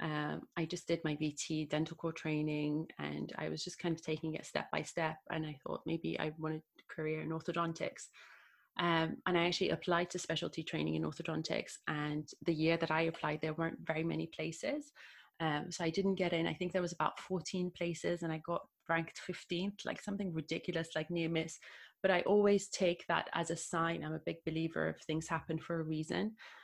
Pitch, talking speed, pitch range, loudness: 165 Hz, 210 wpm, 155-175 Hz, -38 LUFS